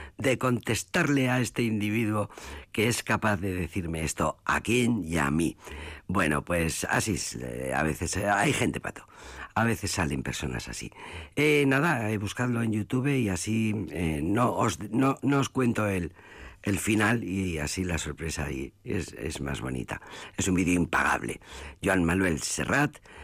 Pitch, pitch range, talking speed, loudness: 100 Hz, 80-120 Hz, 175 wpm, -28 LUFS